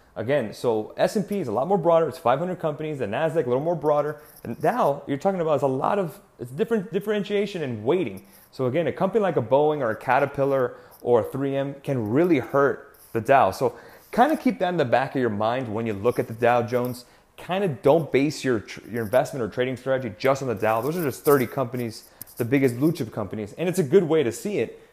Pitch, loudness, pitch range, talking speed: 140 Hz, -24 LUFS, 125-175 Hz, 245 wpm